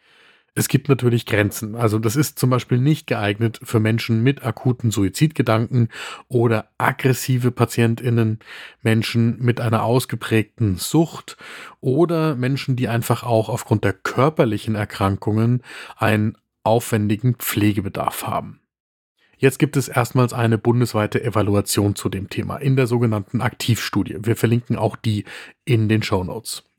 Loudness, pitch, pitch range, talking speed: -20 LUFS, 115 Hz, 110-125 Hz, 130 wpm